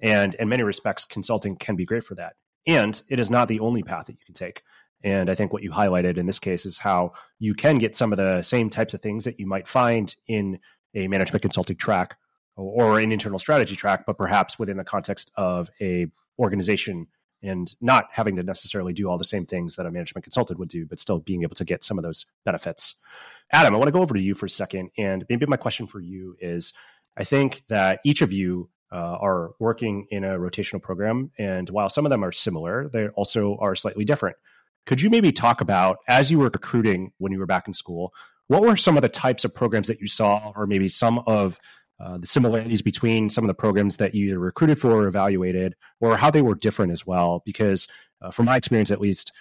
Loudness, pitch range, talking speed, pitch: -23 LUFS, 95-115 Hz, 235 wpm, 100 Hz